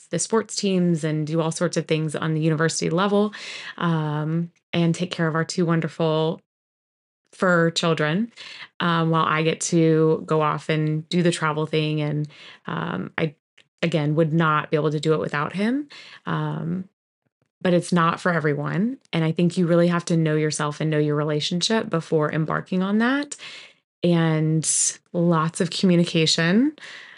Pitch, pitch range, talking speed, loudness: 165 Hz, 155-175 Hz, 165 wpm, -22 LUFS